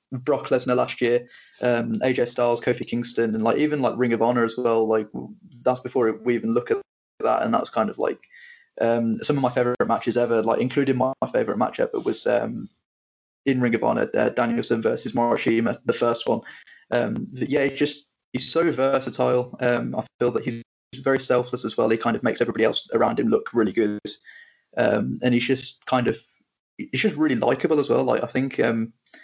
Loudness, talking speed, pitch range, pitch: -23 LUFS, 205 wpm, 115-130 Hz, 120 Hz